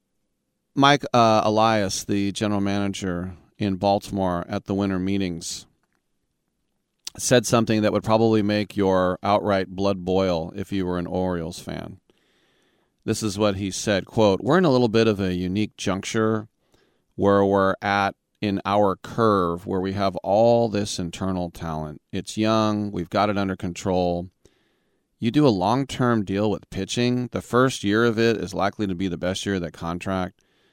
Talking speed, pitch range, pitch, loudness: 165 wpm, 95-110 Hz, 100 Hz, -23 LUFS